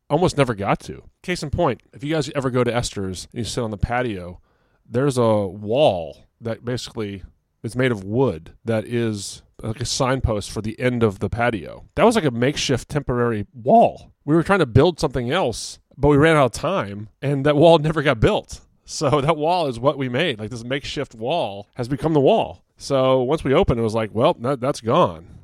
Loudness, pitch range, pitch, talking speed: -21 LUFS, 110-145 Hz, 125 Hz, 215 wpm